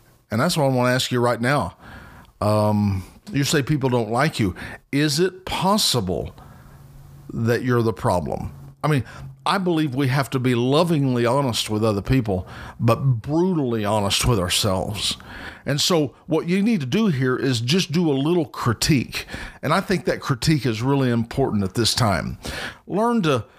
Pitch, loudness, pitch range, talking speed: 130 Hz, -21 LUFS, 115-155 Hz, 175 wpm